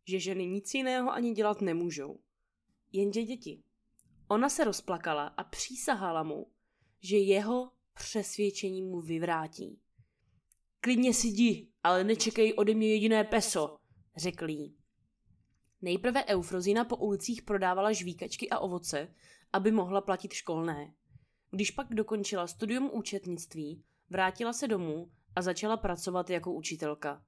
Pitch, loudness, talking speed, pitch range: 195 Hz, -32 LUFS, 120 wpm, 170-220 Hz